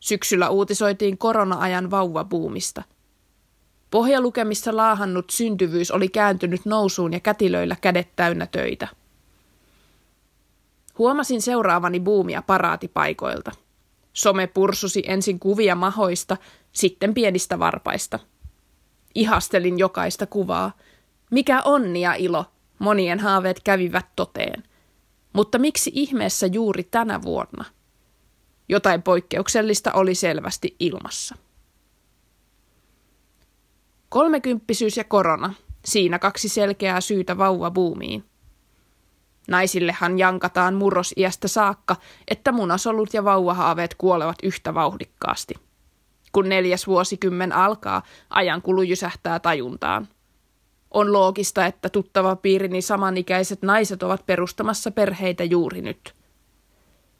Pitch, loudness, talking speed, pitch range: 190 Hz, -21 LUFS, 90 wpm, 180-210 Hz